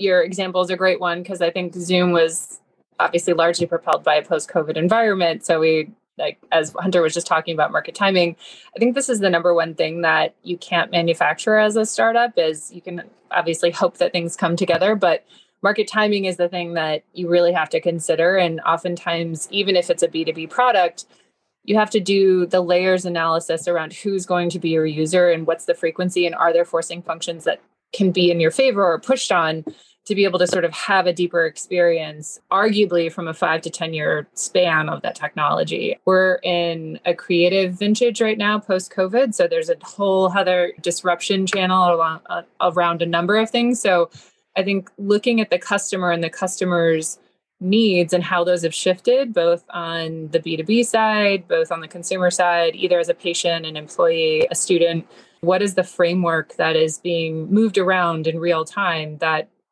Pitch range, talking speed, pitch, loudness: 170-195 Hz, 195 wpm, 175 Hz, -19 LUFS